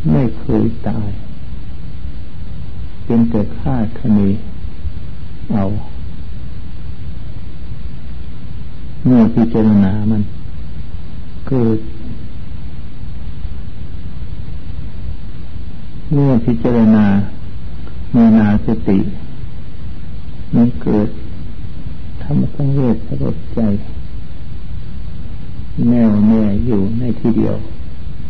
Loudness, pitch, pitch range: -15 LUFS, 100 Hz, 85-110 Hz